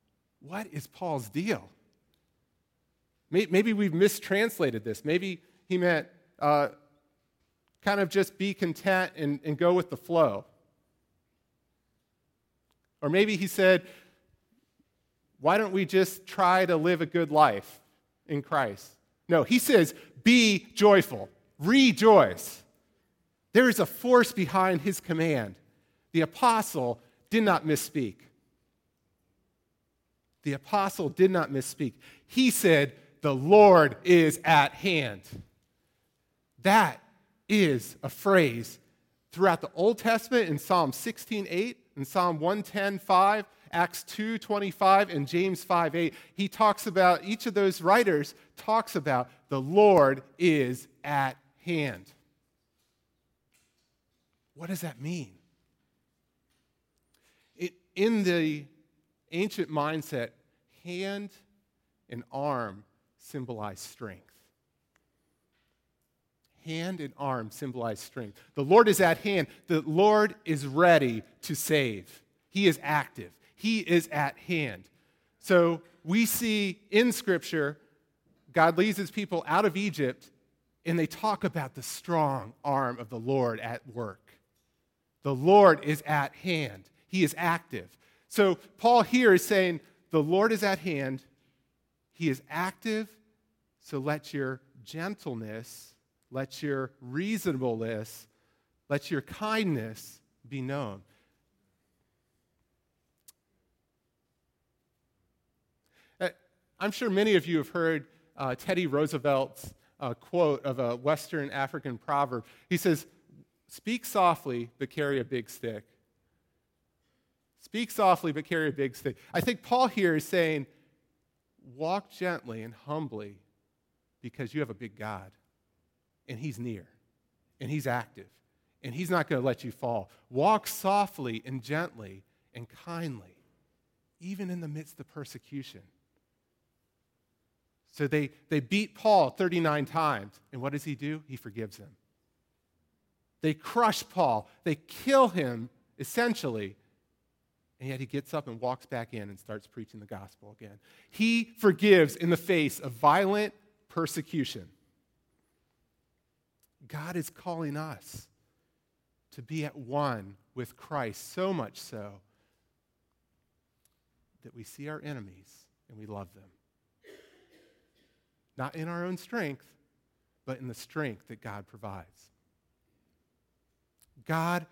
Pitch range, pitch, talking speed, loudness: 125-185 Hz, 155 Hz, 120 wpm, -27 LUFS